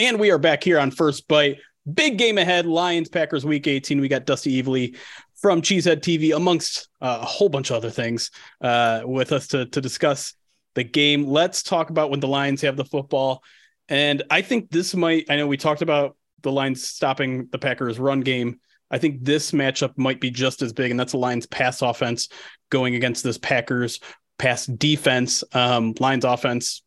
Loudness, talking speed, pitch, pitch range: -21 LUFS, 195 wpm, 140 Hz, 125-150 Hz